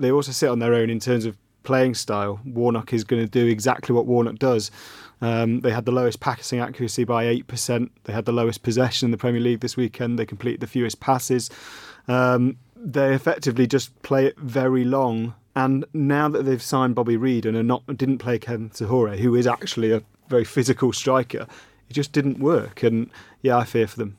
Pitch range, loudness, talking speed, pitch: 115-130 Hz, -22 LUFS, 210 wpm, 120 Hz